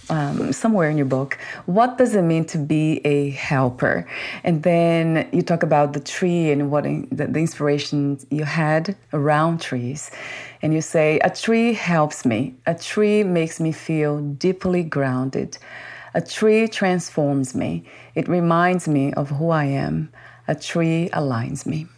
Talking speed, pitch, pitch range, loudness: 160 wpm, 155 Hz, 145-170 Hz, -21 LUFS